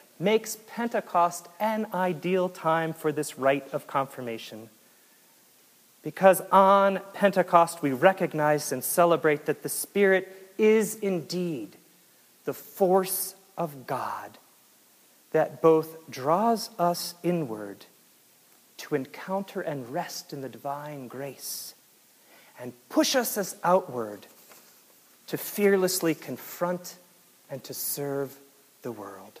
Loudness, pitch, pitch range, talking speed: -26 LUFS, 170 Hz, 140-190 Hz, 105 wpm